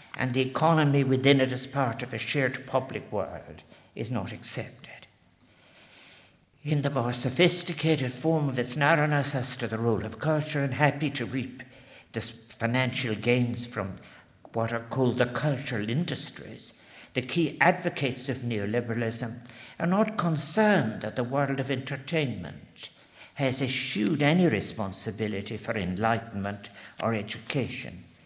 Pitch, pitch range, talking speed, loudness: 130 Hz, 115-145 Hz, 135 wpm, -27 LUFS